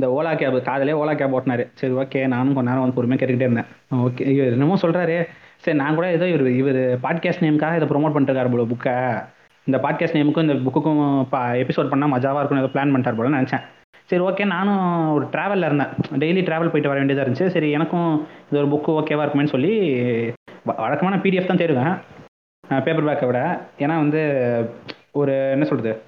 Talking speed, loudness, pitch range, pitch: 185 wpm, -20 LUFS, 130-160 Hz, 145 Hz